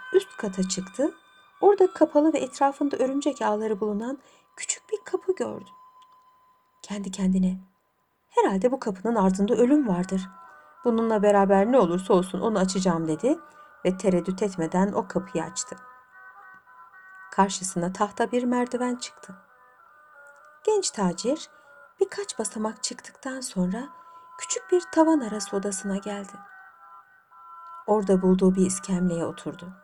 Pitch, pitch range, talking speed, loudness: 215 Hz, 190-290 Hz, 115 wpm, -25 LUFS